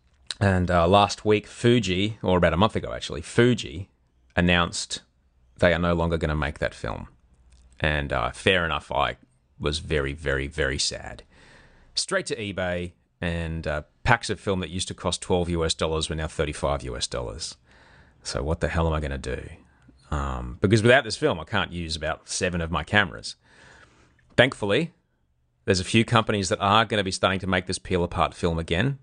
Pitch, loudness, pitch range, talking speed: 85 Hz, -25 LUFS, 70-95 Hz, 190 wpm